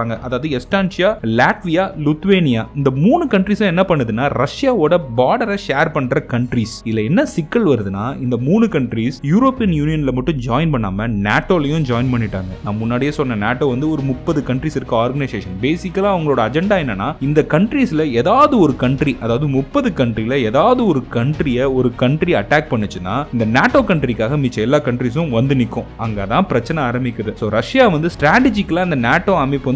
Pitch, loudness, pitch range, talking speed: 140 Hz, -16 LUFS, 120-170 Hz, 155 wpm